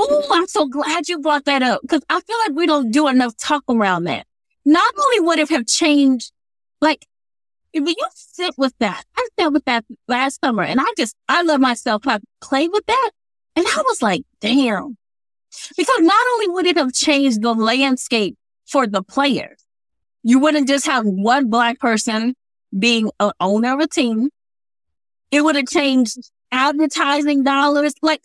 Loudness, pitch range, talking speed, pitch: -17 LUFS, 240-315 Hz, 180 wpm, 275 Hz